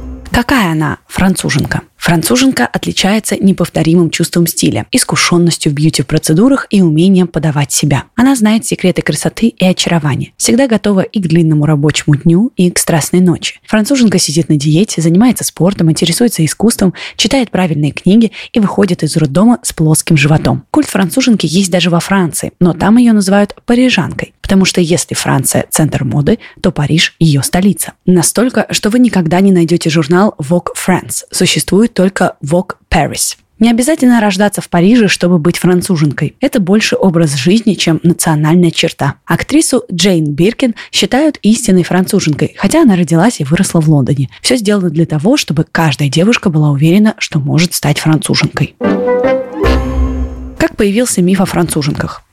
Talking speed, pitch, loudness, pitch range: 150 wpm, 180 Hz, -11 LUFS, 160-210 Hz